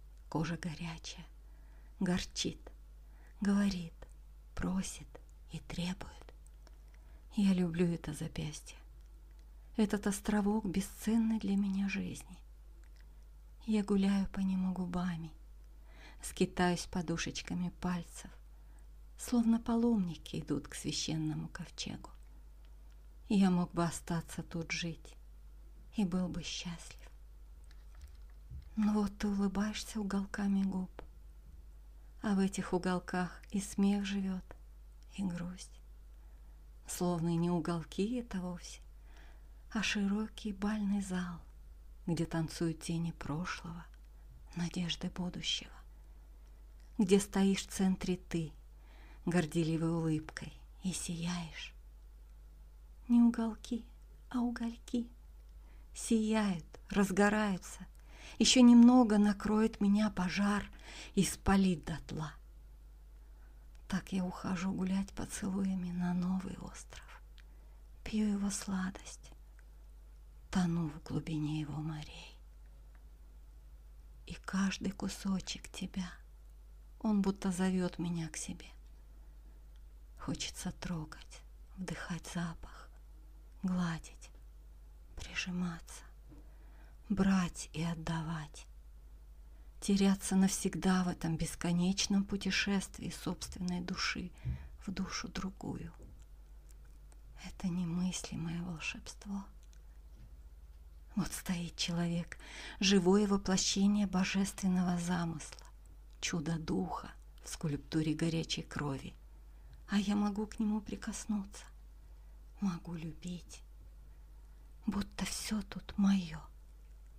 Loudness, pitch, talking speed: -35 LUFS, 170 Hz, 85 wpm